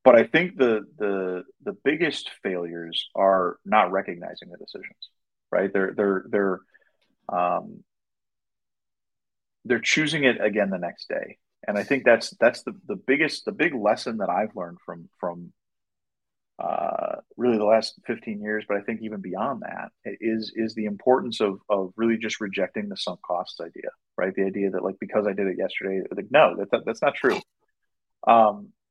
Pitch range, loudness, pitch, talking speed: 95-115 Hz, -24 LUFS, 105 Hz, 175 wpm